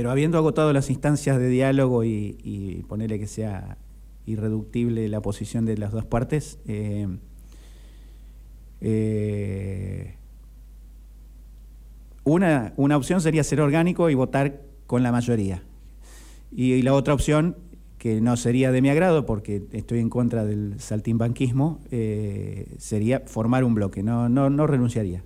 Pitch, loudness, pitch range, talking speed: 115 Hz, -23 LUFS, 100-135 Hz, 140 wpm